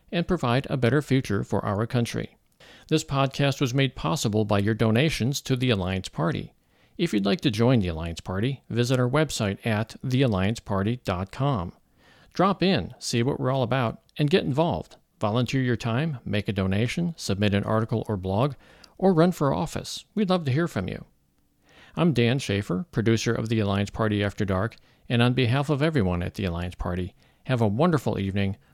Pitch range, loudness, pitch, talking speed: 100-140 Hz, -25 LUFS, 115 Hz, 180 wpm